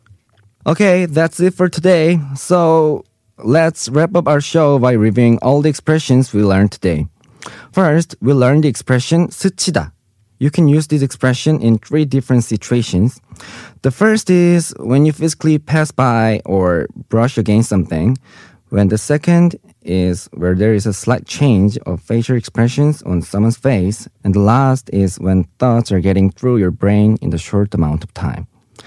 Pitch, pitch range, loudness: 125 Hz, 105-150 Hz, -14 LUFS